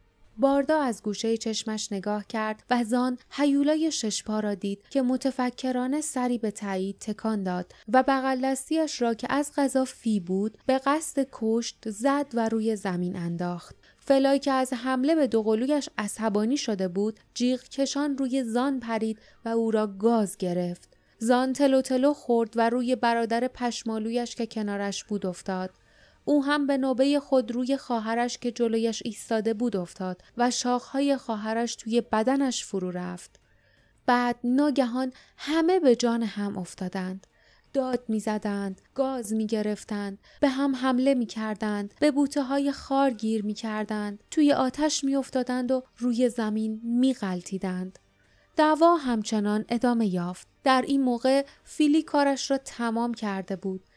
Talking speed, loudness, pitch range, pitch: 140 wpm, -27 LUFS, 215-270 Hz, 240 Hz